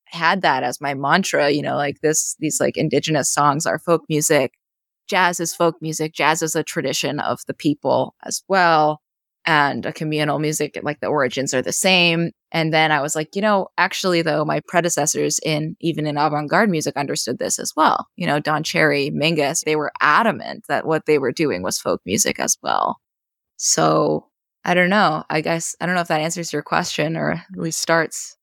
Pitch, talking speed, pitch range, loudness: 155 Hz, 205 wpm, 150-170 Hz, -19 LUFS